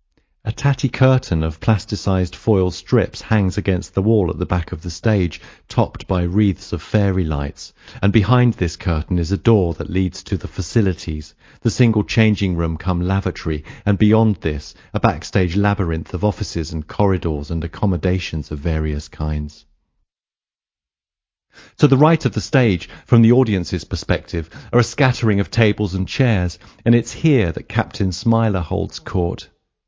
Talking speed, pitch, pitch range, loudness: 165 wpm, 95 Hz, 85-110 Hz, -19 LUFS